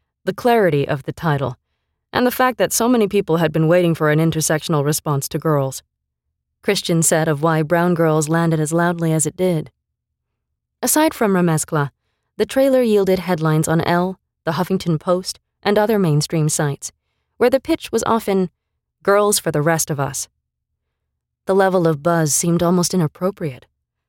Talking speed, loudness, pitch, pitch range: 165 wpm, -18 LUFS, 165 Hz, 150-190 Hz